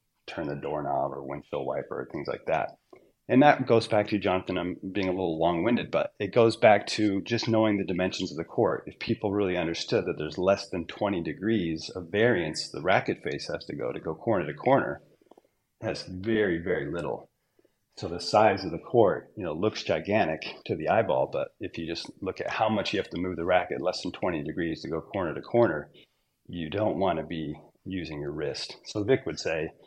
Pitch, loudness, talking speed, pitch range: 95 Hz, -28 LUFS, 215 wpm, 85-110 Hz